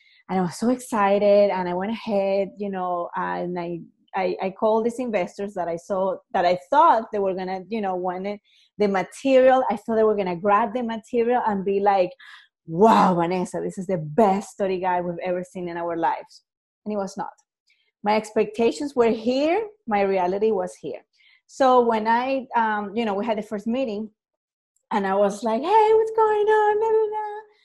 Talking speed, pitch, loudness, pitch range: 195 wpm, 210 Hz, -22 LUFS, 190-245 Hz